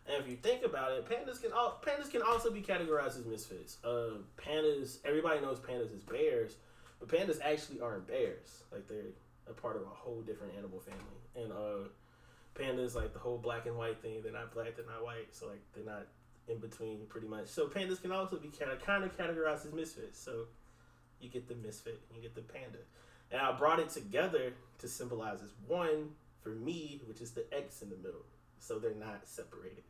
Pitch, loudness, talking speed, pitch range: 130 Hz, -39 LUFS, 215 wpm, 115-185 Hz